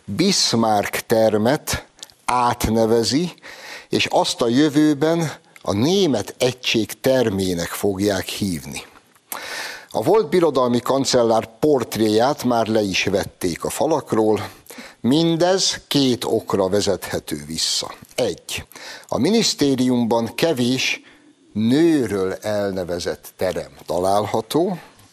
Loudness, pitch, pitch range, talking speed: -20 LUFS, 120 Hz, 105-150 Hz, 90 wpm